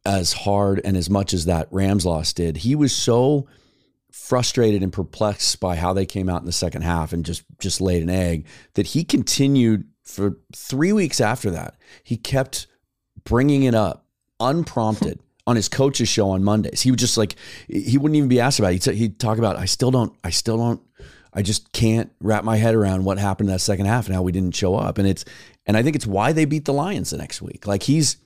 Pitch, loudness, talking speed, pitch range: 105 Hz, -21 LUFS, 225 wpm, 95-125 Hz